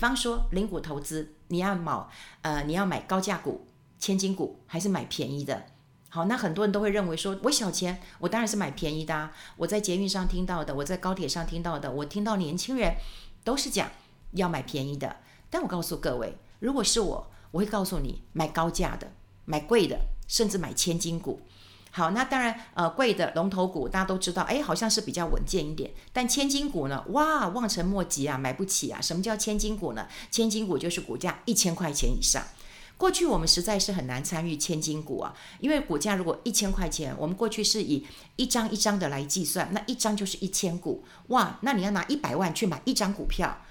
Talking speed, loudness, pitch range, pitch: 310 characters per minute, -28 LUFS, 160-215 Hz, 185 Hz